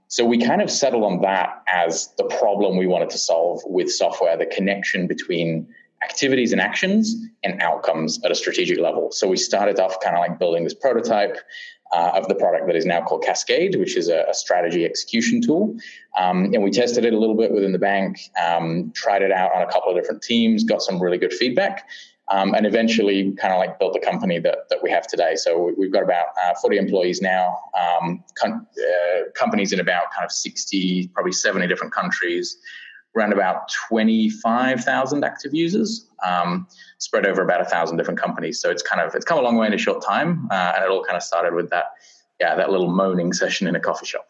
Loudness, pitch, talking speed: -20 LUFS, 225 Hz, 220 wpm